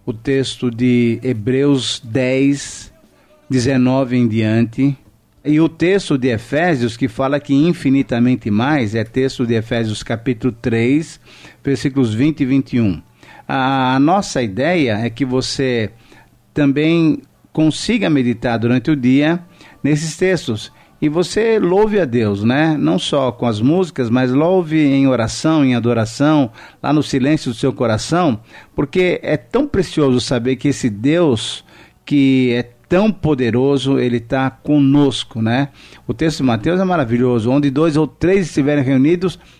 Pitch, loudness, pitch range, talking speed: 135 Hz, -16 LUFS, 120-150 Hz, 140 wpm